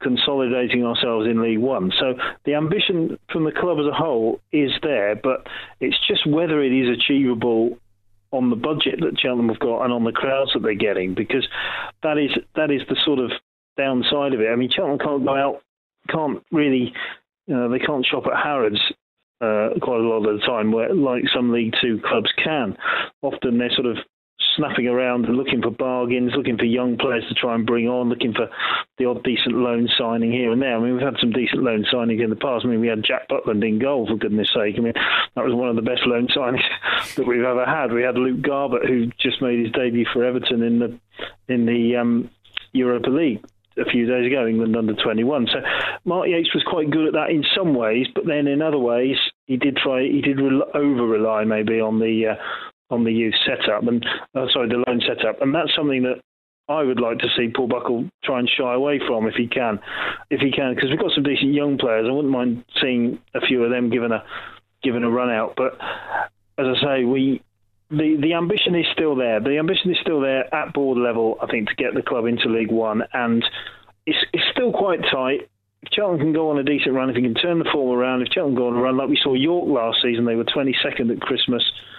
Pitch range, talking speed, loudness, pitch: 115-140 Hz, 230 wpm, -20 LUFS, 125 Hz